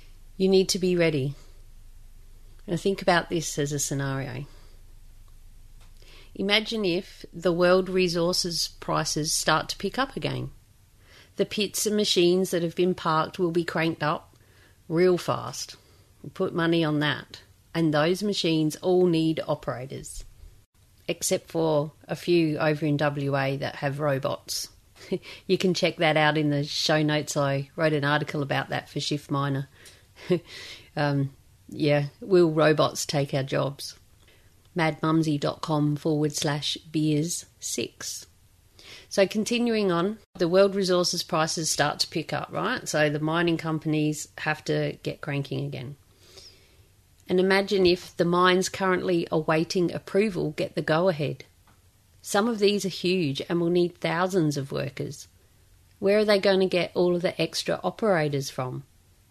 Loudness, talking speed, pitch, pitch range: -25 LUFS, 145 wpm, 155 Hz, 125-180 Hz